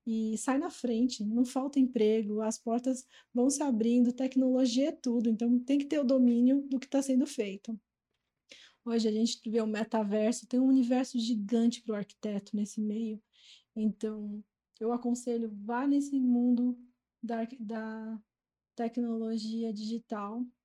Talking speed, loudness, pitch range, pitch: 150 wpm, -31 LUFS, 220-255 Hz, 235 Hz